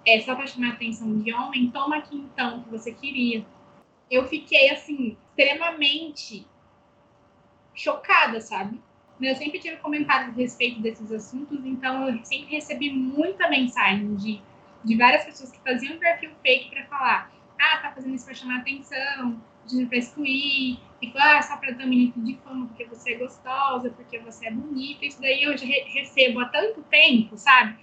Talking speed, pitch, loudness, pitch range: 170 wpm, 260 Hz, -23 LUFS, 240-285 Hz